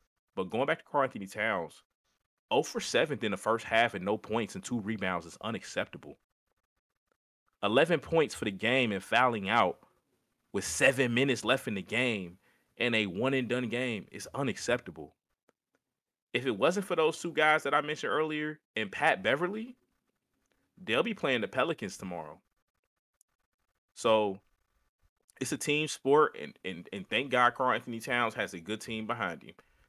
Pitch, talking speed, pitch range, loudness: 120 Hz, 170 wpm, 105-150 Hz, -30 LUFS